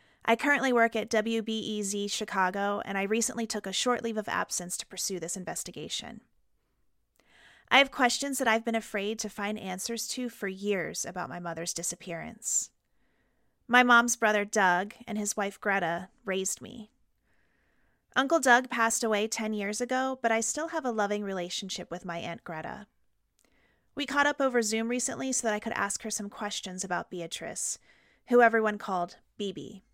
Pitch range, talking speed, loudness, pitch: 195-235 Hz, 170 wpm, -29 LUFS, 215 Hz